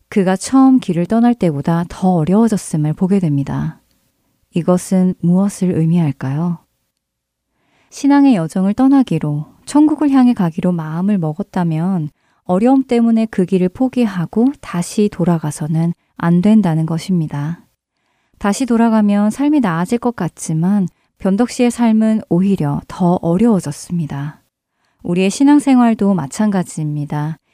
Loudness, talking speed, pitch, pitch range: -15 LUFS, 290 characters per minute, 185 Hz, 165-225 Hz